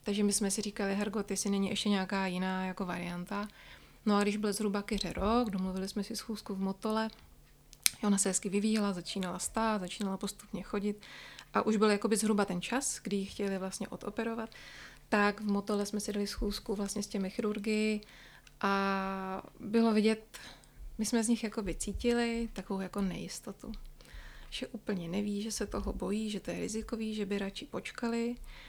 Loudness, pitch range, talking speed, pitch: -34 LUFS, 195-220 Hz, 175 wpm, 205 Hz